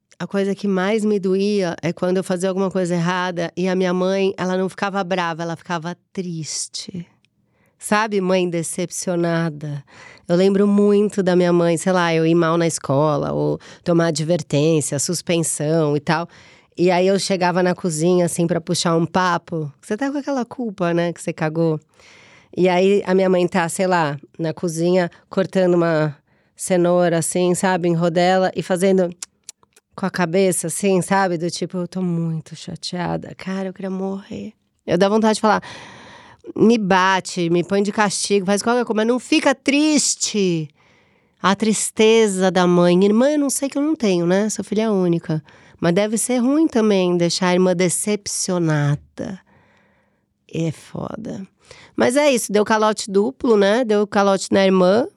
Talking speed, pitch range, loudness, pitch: 170 wpm, 170-200 Hz, -19 LUFS, 185 Hz